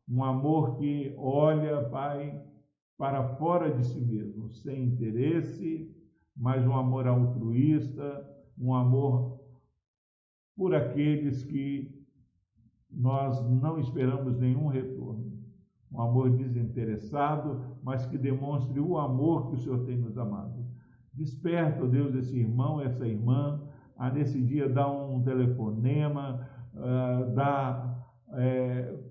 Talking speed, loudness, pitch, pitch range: 115 wpm, -30 LUFS, 130 Hz, 125-140 Hz